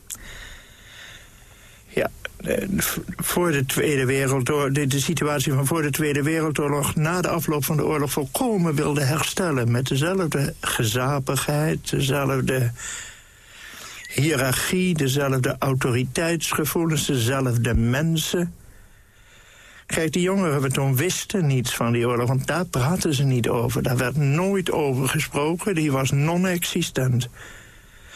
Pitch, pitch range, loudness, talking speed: 145 Hz, 135-160 Hz, -22 LUFS, 115 wpm